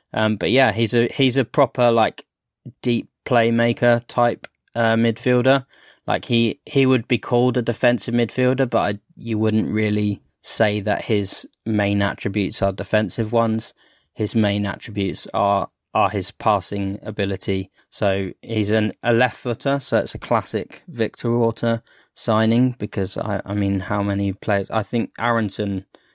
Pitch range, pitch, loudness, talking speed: 100-120 Hz, 110 Hz, -21 LUFS, 155 wpm